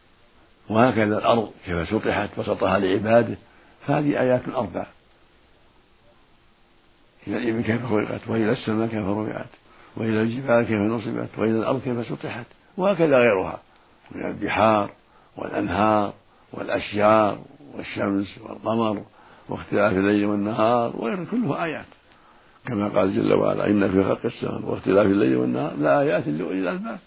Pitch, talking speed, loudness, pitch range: 110 Hz, 115 wpm, -23 LUFS, 105-115 Hz